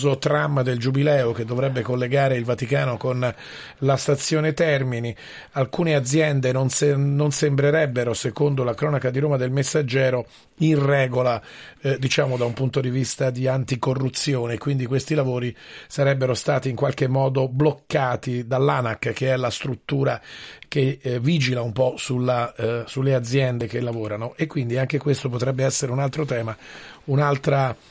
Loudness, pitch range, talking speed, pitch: -22 LUFS, 125-140 Hz, 155 wpm, 130 Hz